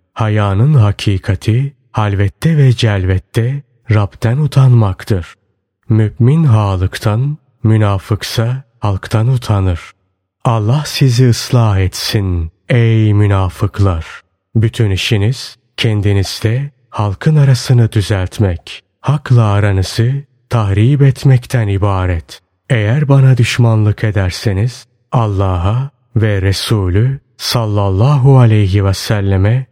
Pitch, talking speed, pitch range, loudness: 110 Hz, 80 wpm, 100-125 Hz, -13 LUFS